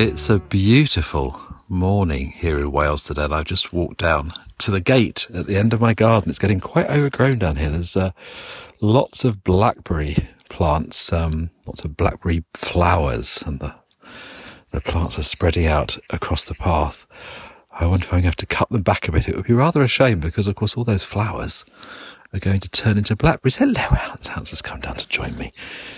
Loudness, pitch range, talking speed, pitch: -19 LUFS, 85-110 Hz, 205 wpm, 95 Hz